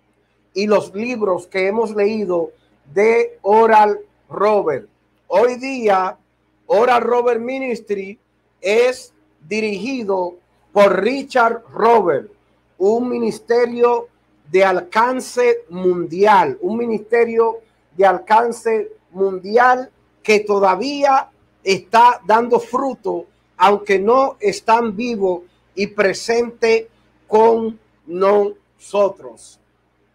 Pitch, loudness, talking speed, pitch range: 220 Hz, -17 LUFS, 85 wpm, 195-235 Hz